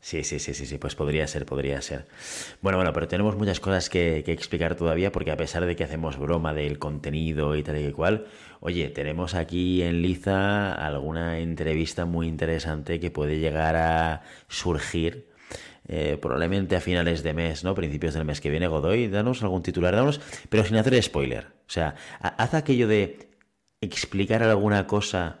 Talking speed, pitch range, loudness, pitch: 180 wpm, 75-95 Hz, -26 LUFS, 85 Hz